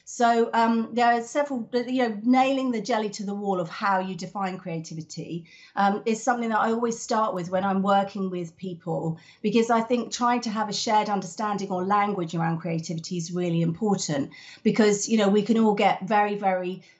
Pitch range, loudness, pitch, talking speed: 180-230 Hz, -25 LUFS, 205 Hz, 200 wpm